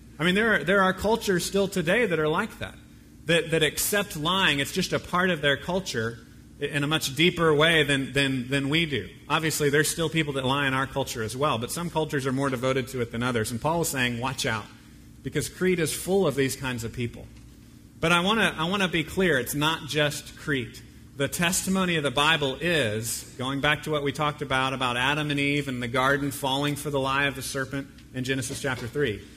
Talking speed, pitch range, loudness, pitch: 230 wpm, 130-160 Hz, -25 LUFS, 145 Hz